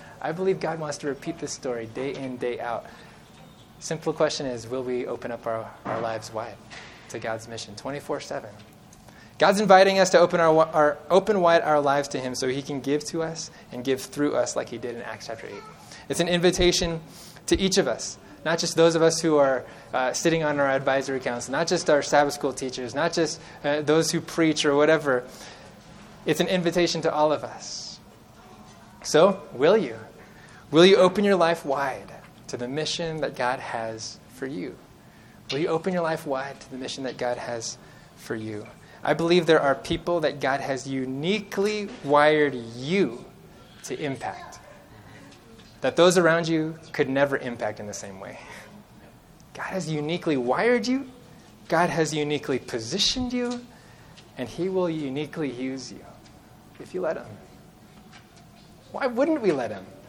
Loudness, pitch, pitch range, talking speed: -24 LUFS, 150 Hz, 130-170 Hz, 180 wpm